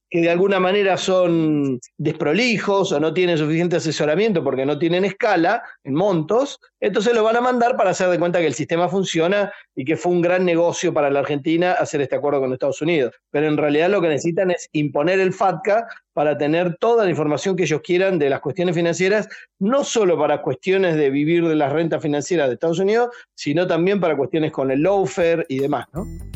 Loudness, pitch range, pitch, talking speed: -19 LUFS, 150-190 Hz, 170 Hz, 205 wpm